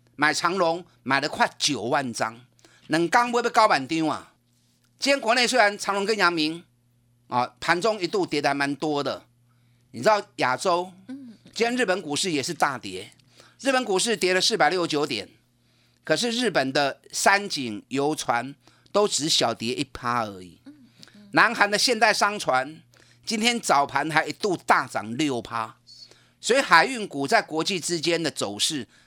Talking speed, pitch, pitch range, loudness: 235 characters per minute, 160 Hz, 125-205 Hz, -23 LUFS